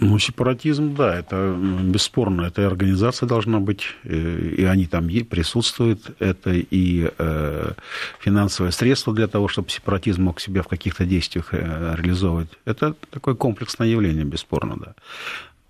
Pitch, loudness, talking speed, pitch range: 95 Hz, -22 LUFS, 125 wpm, 85-115 Hz